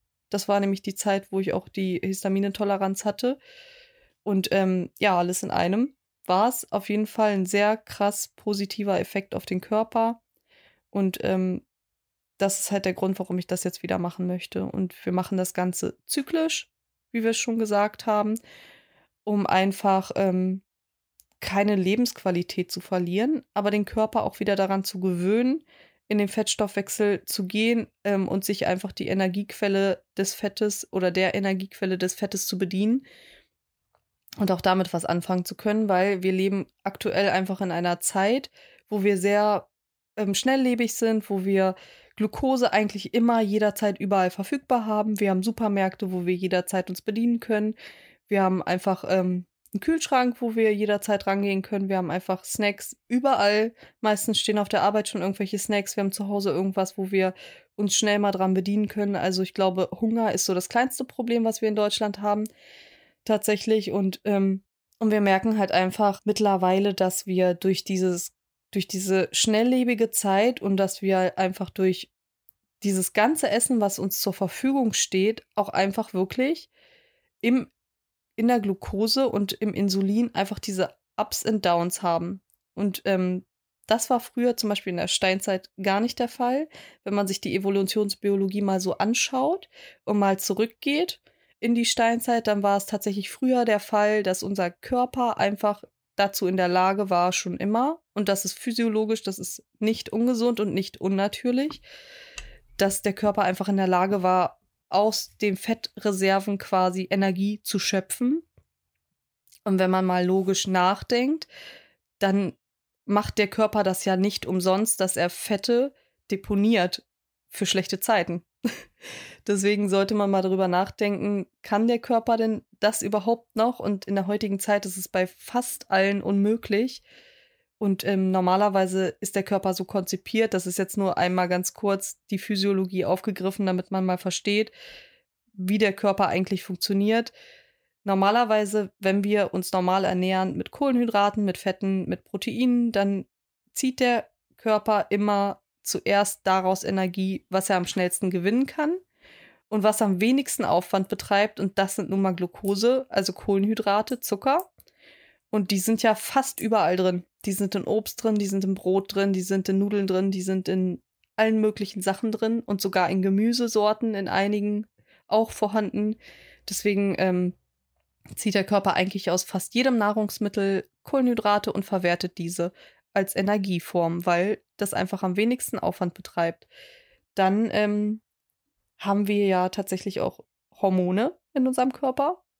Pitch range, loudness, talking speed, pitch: 190-220 Hz, -25 LUFS, 160 wpm, 200 Hz